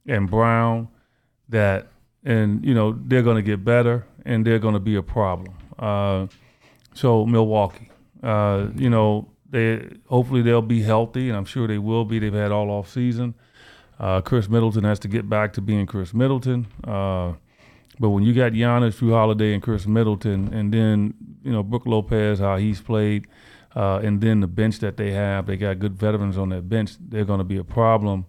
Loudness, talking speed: -21 LUFS, 195 wpm